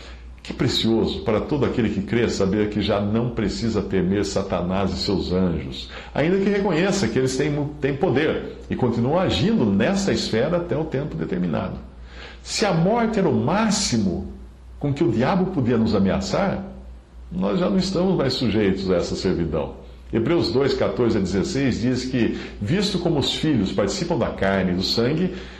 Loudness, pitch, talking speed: -22 LUFS, 115 Hz, 170 wpm